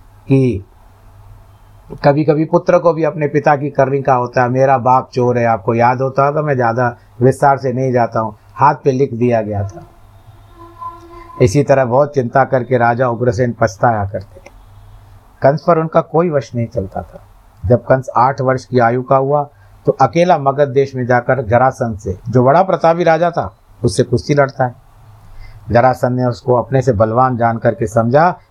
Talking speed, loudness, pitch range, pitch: 180 wpm, -14 LUFS, 110-140 Hz, 125 Hz